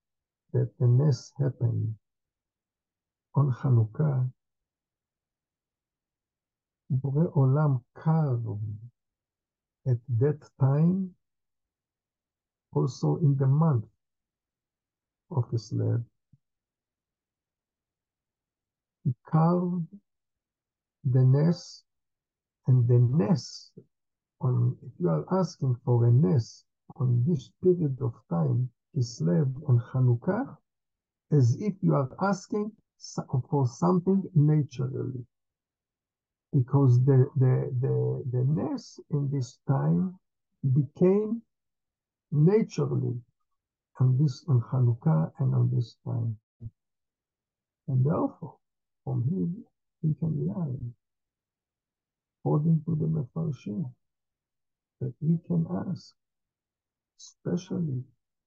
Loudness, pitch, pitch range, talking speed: -27 LUFS, 130 Hz, 115-160 Hz, 85 wpm